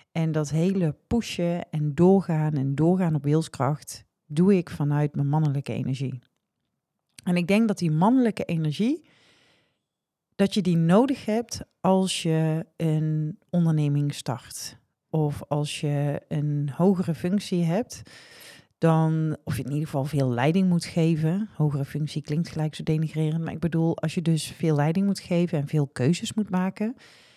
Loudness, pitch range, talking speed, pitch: -25 LUFS, 150-180 Hz, 155 wpm, 160 Hz